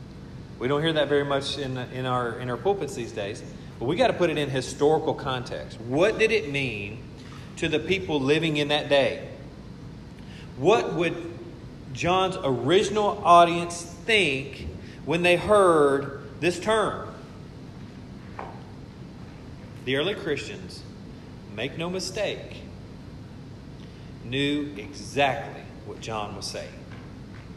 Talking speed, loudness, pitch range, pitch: 125 wpm, -25 LUFS, 130-170 Hz, 145 Hz